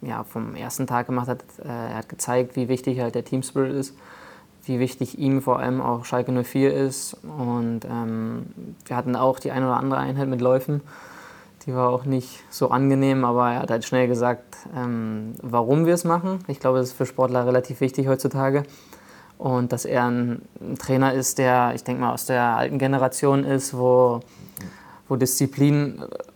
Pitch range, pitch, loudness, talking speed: 125-135 Hz, 130 Hz, -23 LUFS, 180 wpm